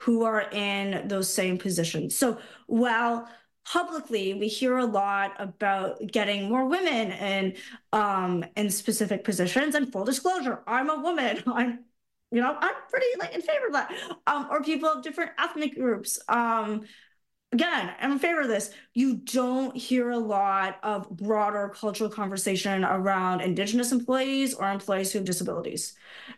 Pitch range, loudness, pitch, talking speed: 195-255 Hz, -27 LUFS, 220 Hz, 155 wpm